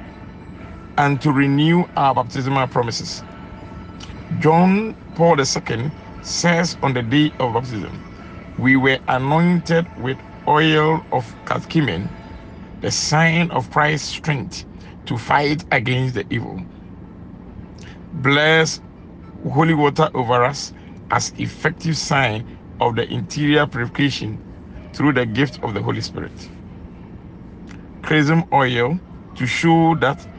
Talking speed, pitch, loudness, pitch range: 110 wpm, 140 Hz, -18 LUFS, 120-155 Hz